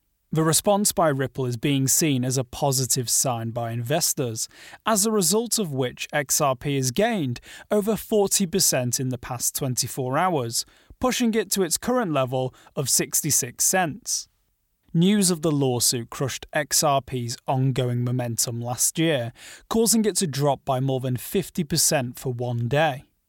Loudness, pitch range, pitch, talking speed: -23 LUFS, 125-180 Hz, 140 Hz, 150 wpm